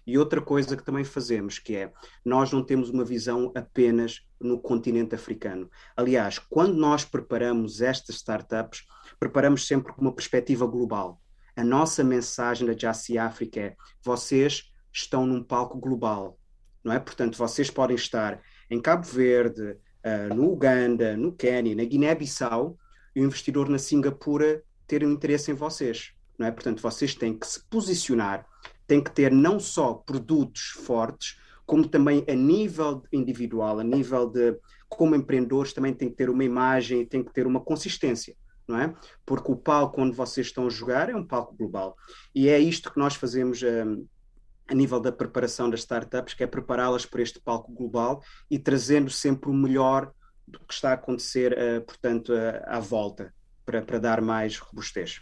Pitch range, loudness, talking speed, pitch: 115-140 Hz, -26 LUFS, 170 wpm, 125 Hz